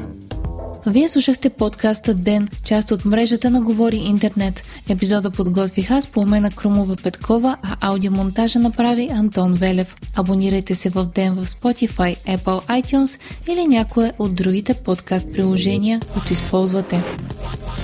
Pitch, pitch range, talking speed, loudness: 205 Hz, 190-230 Hz, 125 wpm, -18 LUFS